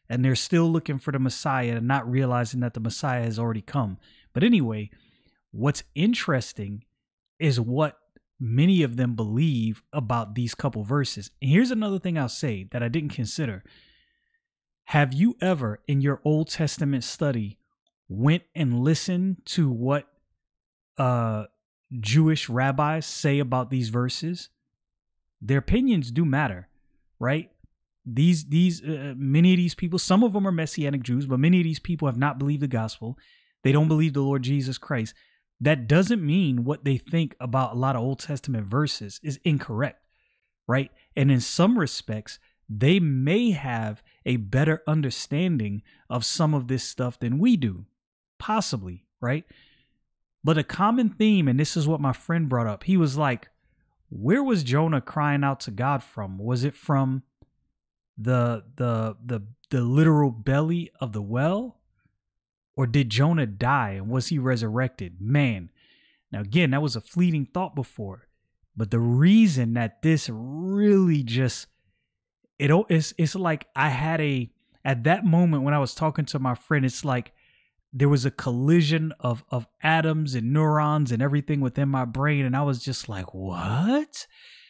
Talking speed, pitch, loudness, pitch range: 165 wpm, 140 Hz, -24 LUFS, 120-160 Hz